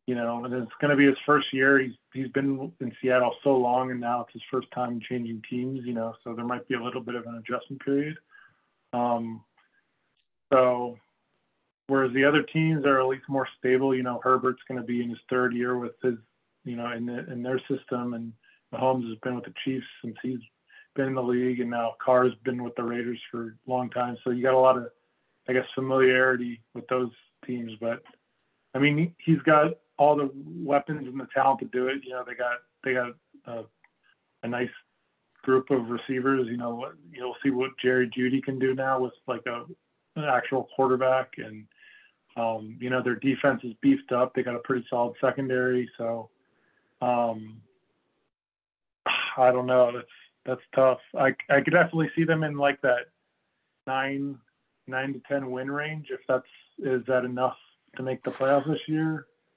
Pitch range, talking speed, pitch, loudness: 120-135 Hz, 195 wpm, 130 Hz, -27 LUFS